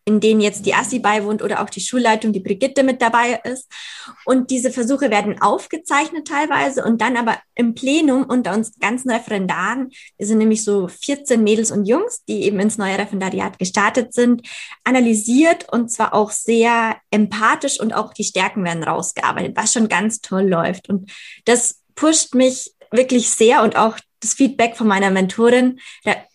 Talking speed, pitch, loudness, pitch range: 170 wpm, 225 Hz, -17 LUFS, 210-255 Hz